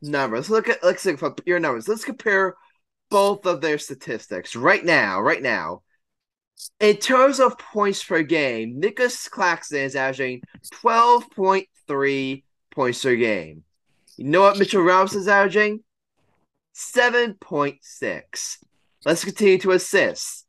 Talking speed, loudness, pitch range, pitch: 145 wpm, -20 LUFS, 140-215 Hz, 190 Hz